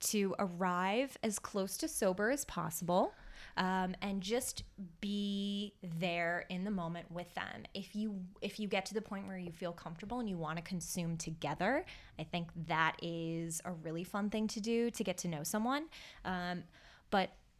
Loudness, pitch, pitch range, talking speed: -38 LUFS, 185 Hz, 170-210 Hz, 180 wpm